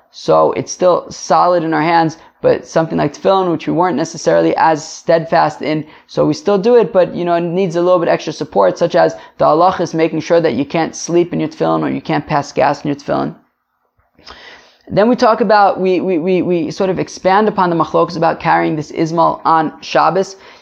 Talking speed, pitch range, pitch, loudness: 220 wpm, 160-190 Hz, 170 Hz, -14 LUFS